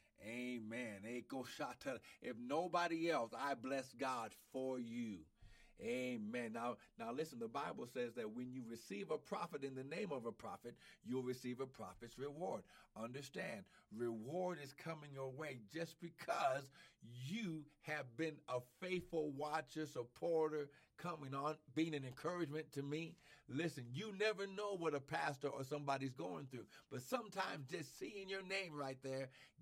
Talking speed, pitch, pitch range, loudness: 150 wpm, 145 Hz, 130-175 Hz, -46 LUFS